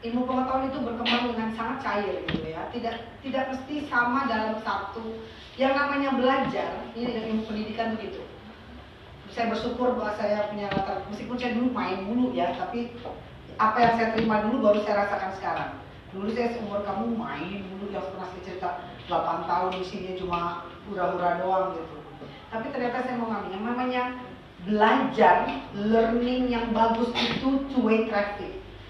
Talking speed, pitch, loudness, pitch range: 160 wpm, 225 Hz, -27 LUFS, 195-245 Hz